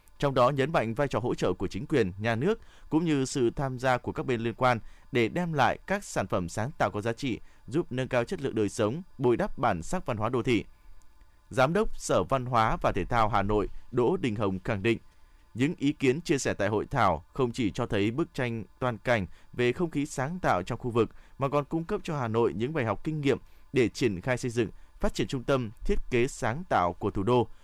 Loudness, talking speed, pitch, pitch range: -29 LUFS, 250 wpm, 125 Hz, 105-140 Hz